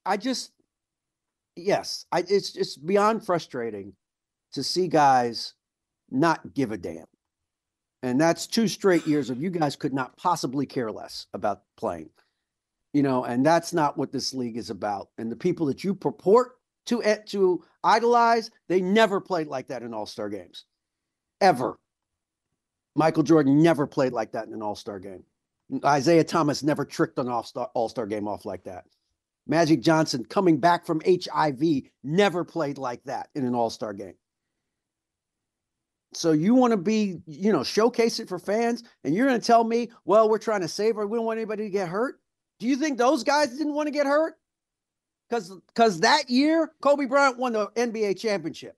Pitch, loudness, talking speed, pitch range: 185 Hz, -24 LUFS, 175 wpm, 145-230 Hz